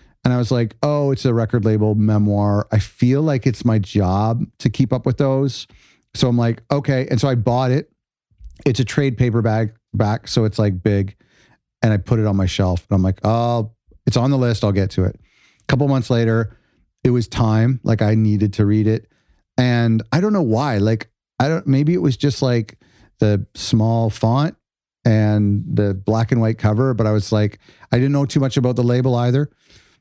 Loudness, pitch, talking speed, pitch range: -18 LUFS, 115 Hz, 210 wpm, 105-130 Hz